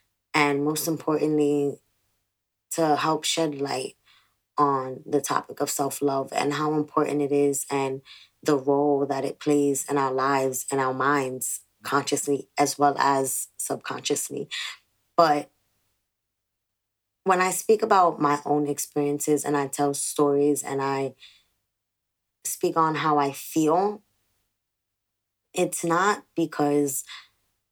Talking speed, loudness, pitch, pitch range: 125 wpm, -25 LUFS, 140 Hz, 115-150 Hz